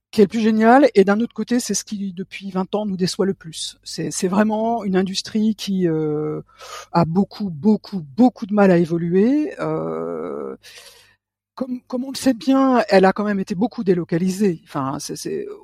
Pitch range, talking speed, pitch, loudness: 175-225 Hz, 195 wpm, 200 Hz, -20 LUFS